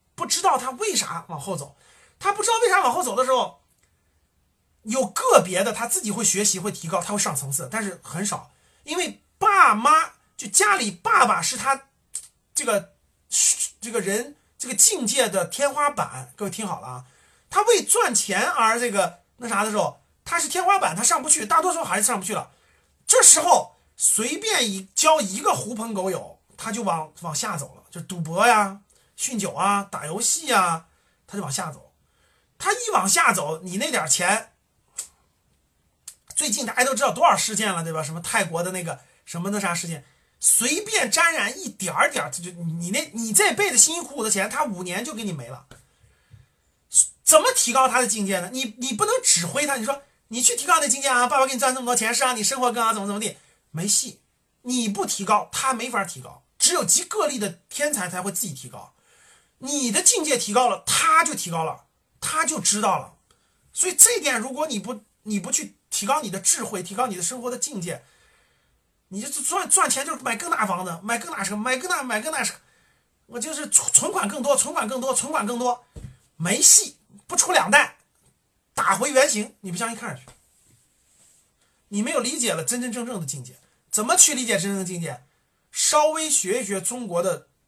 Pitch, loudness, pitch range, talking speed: 235 Hz, -21 LUFS, 195-285 Hz, 280 characters per minute